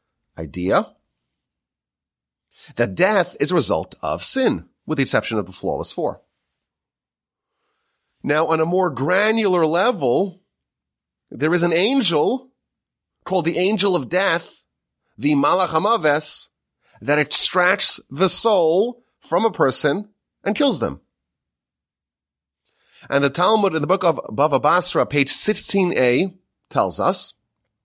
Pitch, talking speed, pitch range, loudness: 175 Hz, 120 wpm, 145-210 Hz, -19 LUFS